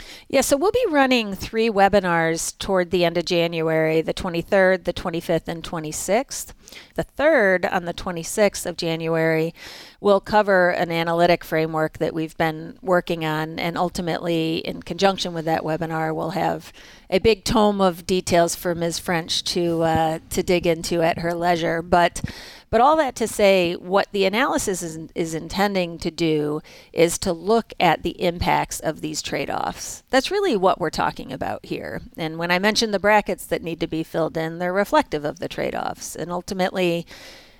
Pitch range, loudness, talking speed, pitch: 165-195 Hz, -22 LUFS, 175 wpm, 175 Hz